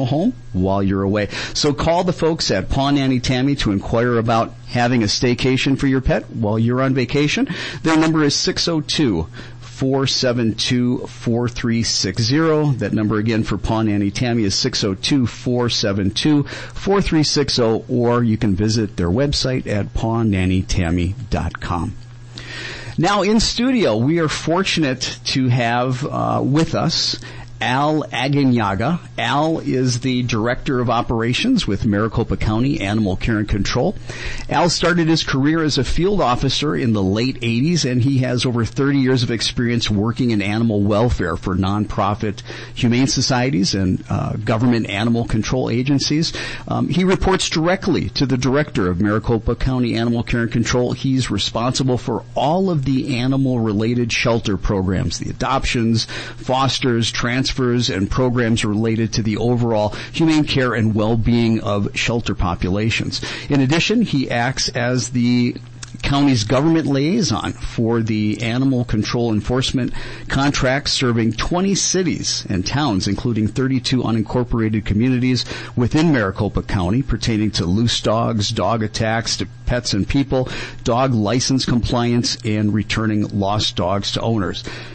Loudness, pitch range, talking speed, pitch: -18 LUFS, 110-135 Hz, 140 wpm, 120 Hz